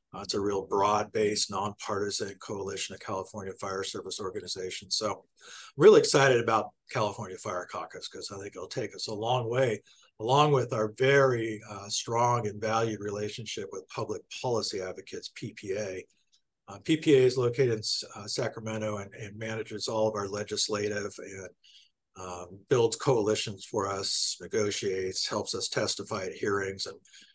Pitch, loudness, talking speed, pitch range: 110 Hz, -29 LUFS, 155 wpm, 100-120 Hz